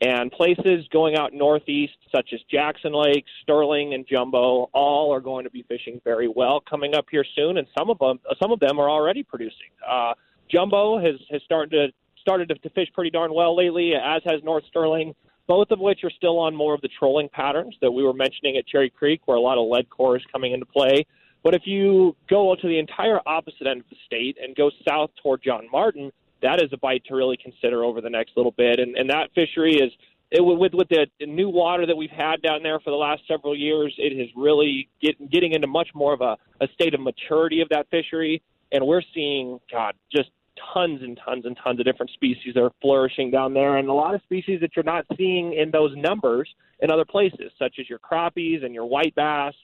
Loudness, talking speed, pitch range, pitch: -22 LUFS, 225 wpm, 130-165 Hz, 150 Hz